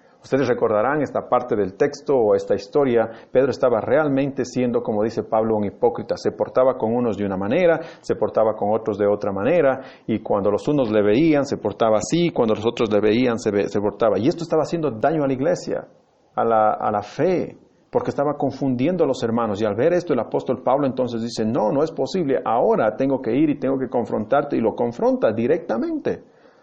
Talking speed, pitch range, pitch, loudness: 210 wpm, 110-155 Hz, 130 Hz, -21 LUFS